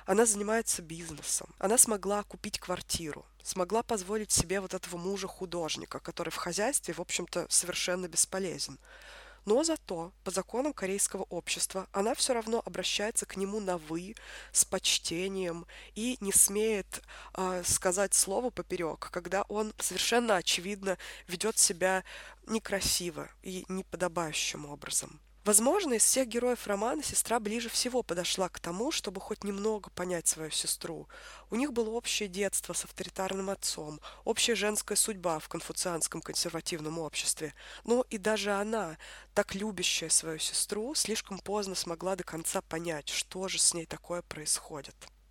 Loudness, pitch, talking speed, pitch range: -31 LUFS, 190 Hz, 140 wpm, 175-215 Hz